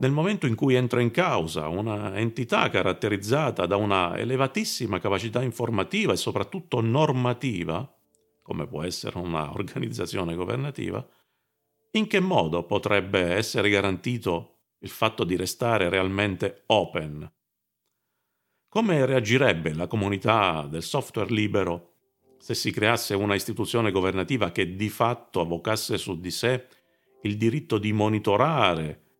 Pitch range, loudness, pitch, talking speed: 95-125 Hz, -25 LUFS, 110 Hz, 125 wpm